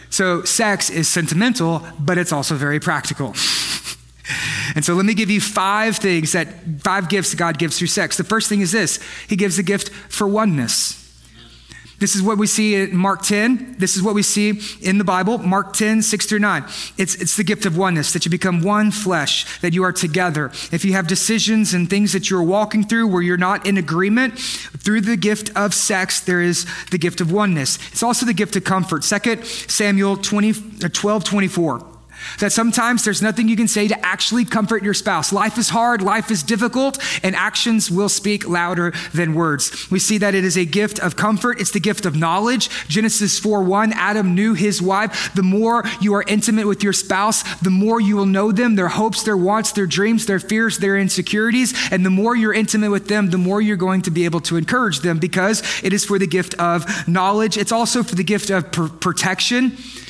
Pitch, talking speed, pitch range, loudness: 200 Hz, 210 wpm, 180-215 Hz, -17 LUFS